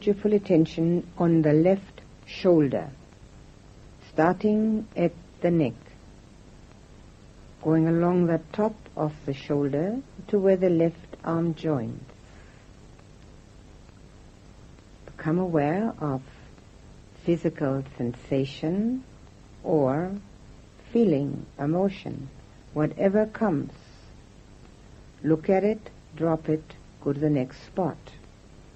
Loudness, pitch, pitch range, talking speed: -26 LUFS, 160 Hz, 145-190 Hz, 90 wpm